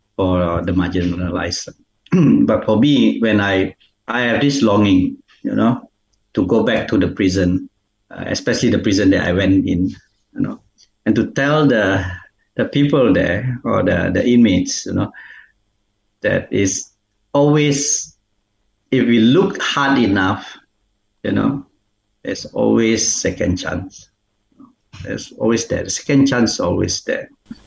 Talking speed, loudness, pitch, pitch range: 145 wpm, -17 LUFS, 105 Hz, 95-120 Hz